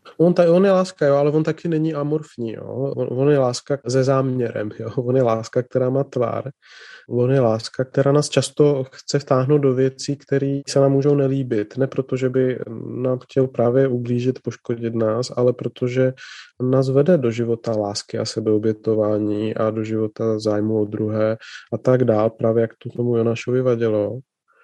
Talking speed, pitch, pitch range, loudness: 180 wpm, 130 Hz, 115-135 Hz, -20 LUFS